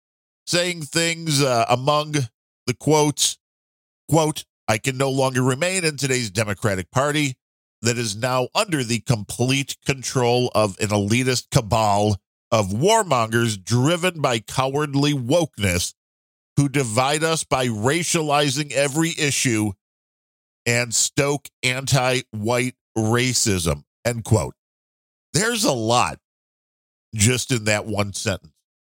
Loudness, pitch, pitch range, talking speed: -21 LUFS, 125 Hz, 110-145 Hz, 110 wpm